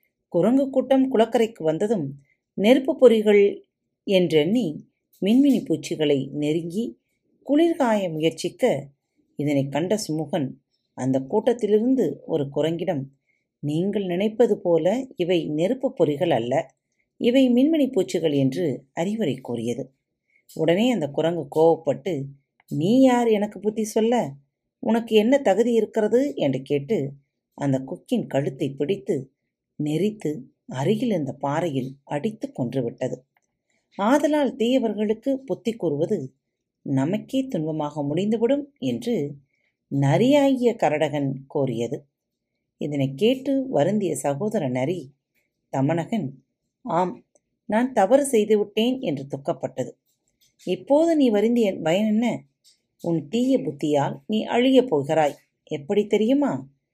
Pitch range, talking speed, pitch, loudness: 145-230 Hz, 100 wpm, 180 Hz, -23 LUFS